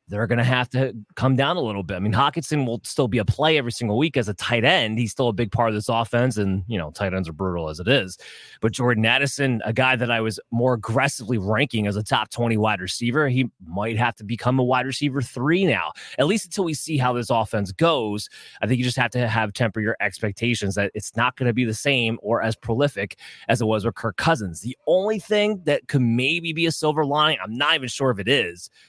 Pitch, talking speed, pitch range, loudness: 120 Hz, 255 wpm, 110-135 Hz, -22 LUFS